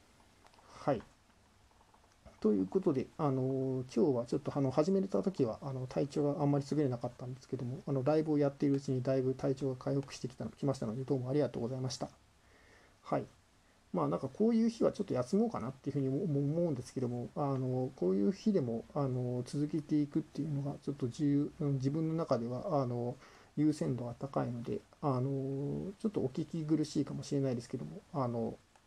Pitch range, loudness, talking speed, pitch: 130-150 Hz, -35 LUFS, 410 characters per minute, 140 Hz